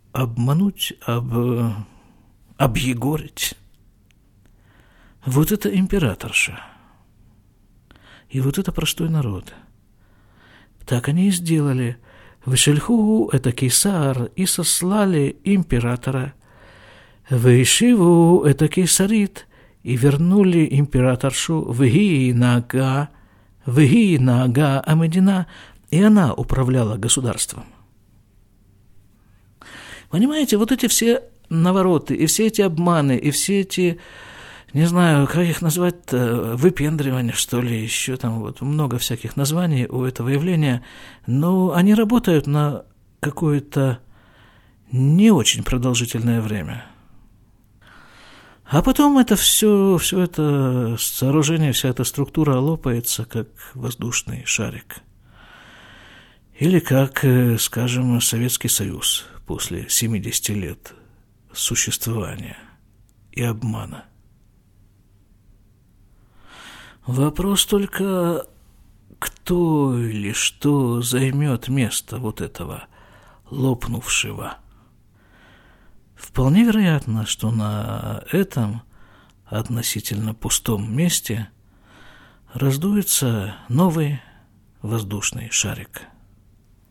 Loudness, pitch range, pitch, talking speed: -19 LUFS, 110-155 Hz, 125 Hz, 85 wpm